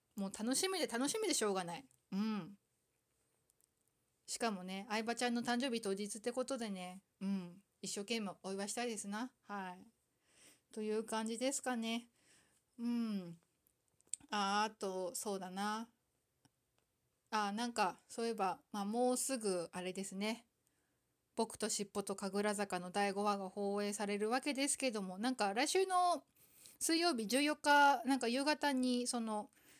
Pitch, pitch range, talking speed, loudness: 220 Hz, 200-250 Hz, 260 characters per minute, -39 LUFS